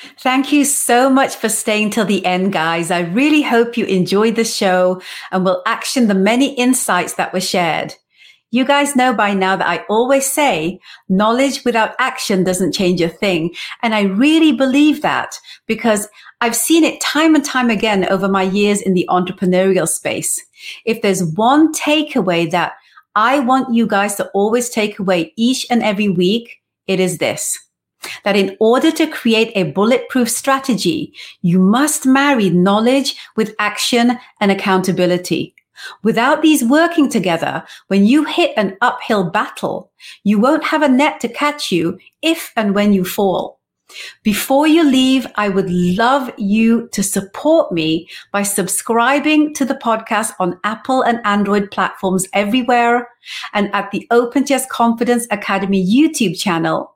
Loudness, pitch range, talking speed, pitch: -15 LUFS, 195-260 Hz, 160 wpm, 225 Hz